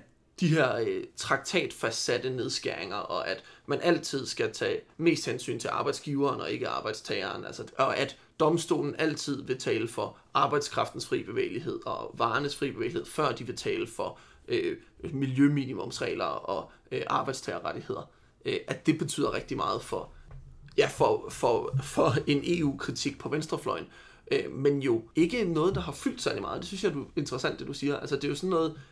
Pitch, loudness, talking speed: 160 Hz, -30 LUFS, 170 wpm